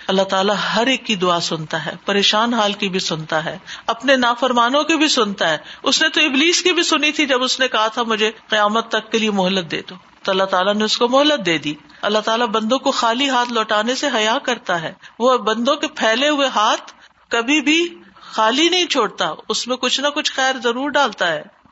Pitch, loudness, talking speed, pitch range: 230 Hz, -17 LUFS, 225 wpm, 205-275 Hz